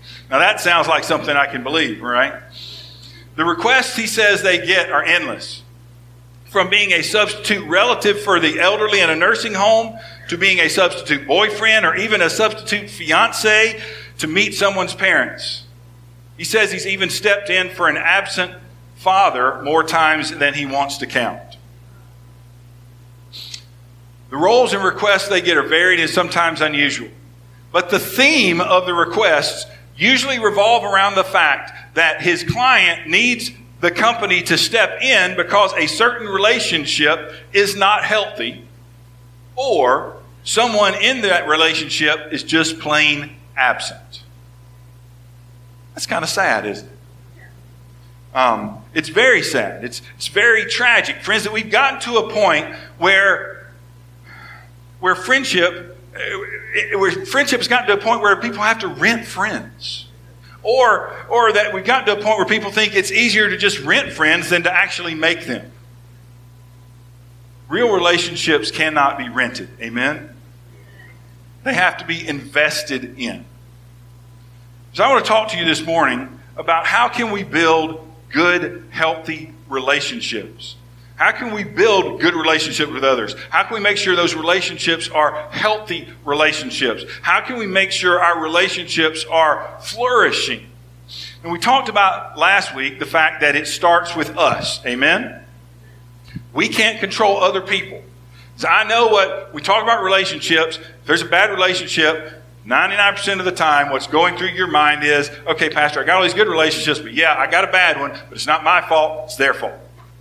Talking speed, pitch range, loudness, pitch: 160 wpm, 120-195 Hz, -15 LUFS, 160 Hz